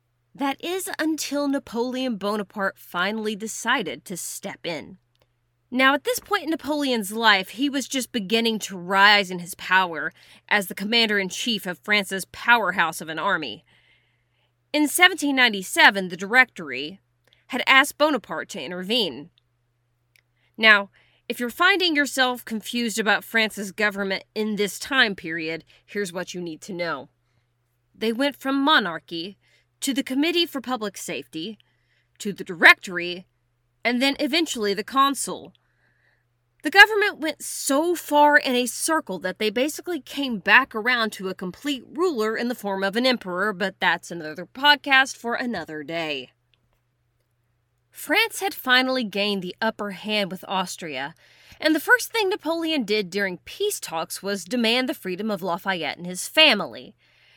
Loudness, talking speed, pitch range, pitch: -22 LUFS, 145 wpm, 175-265 Hz, 210 Hz